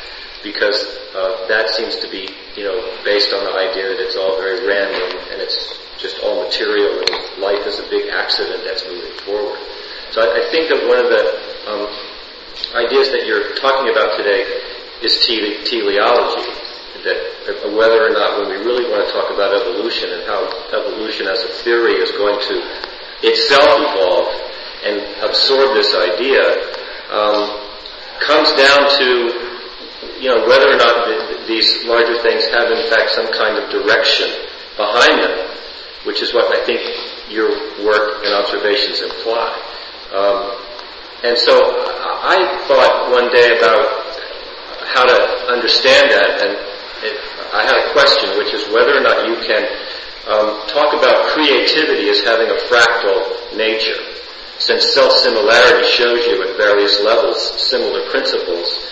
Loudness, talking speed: -14 LUFS, 155 wpm